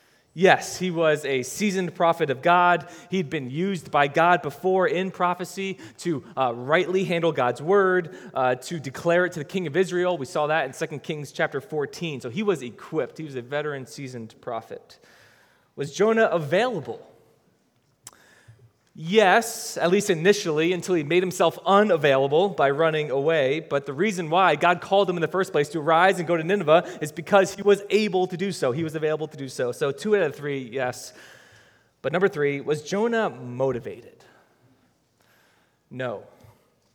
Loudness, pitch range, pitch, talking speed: -23 LUFS, 145-185 Hz, 170 Hz, 175 wpm